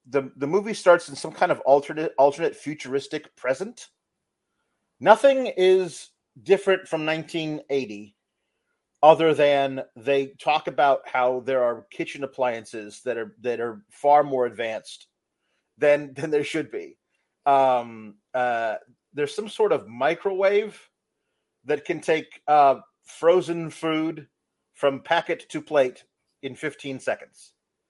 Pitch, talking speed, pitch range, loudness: 145 Hz, 125 wpm, 130-170 Hz, -23 LUFS